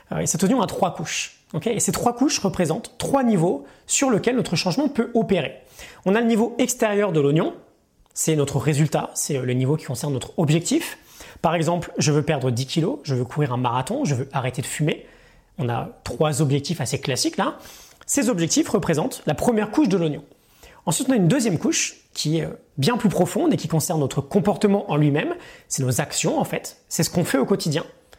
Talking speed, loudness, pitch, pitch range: 205 wpm, -22 LUFS, 165 Hz, 145-210 Hz